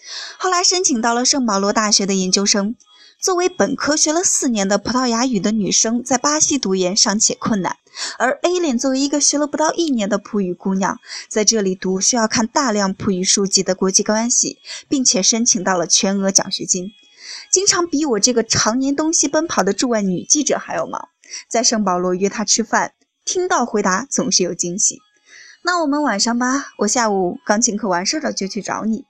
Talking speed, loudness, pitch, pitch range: 300 characters per minute, -17 LUFS, 230 Hz, 200-290 Hz